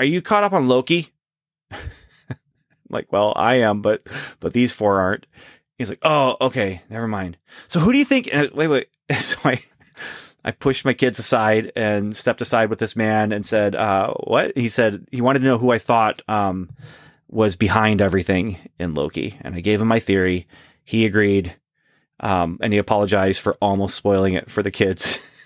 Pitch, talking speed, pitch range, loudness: 110 Hz, 190 wpm, 100-125 Hz, -19 LUFS